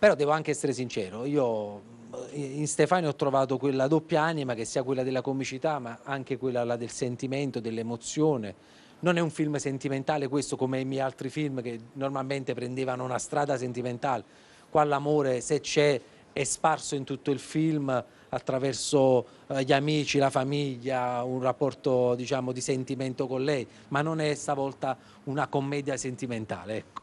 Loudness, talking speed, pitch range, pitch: -29 LUFS, 160 wpm, 125-145 Hz, 135 Hz